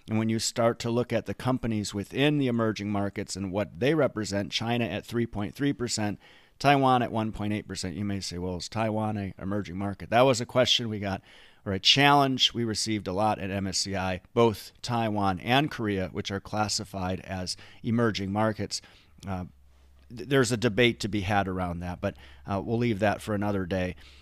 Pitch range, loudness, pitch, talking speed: 95-115 Hz, -27 LUFS, 105 Hz, 185 wpm